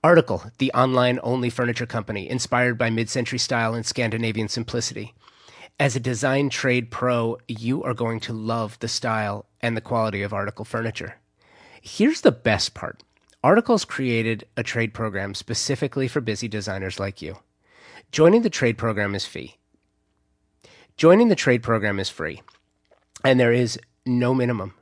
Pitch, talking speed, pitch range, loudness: 115 Hz, 155 wpm, 110-125 Hz, -22 LUFS